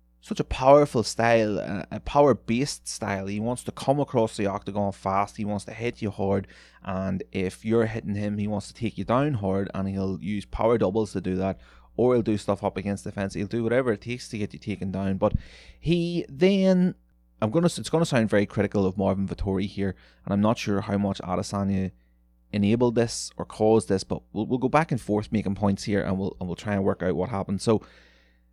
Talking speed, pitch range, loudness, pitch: 225 wpm, 95-115 Hz, -26 LUFS, 100 Hz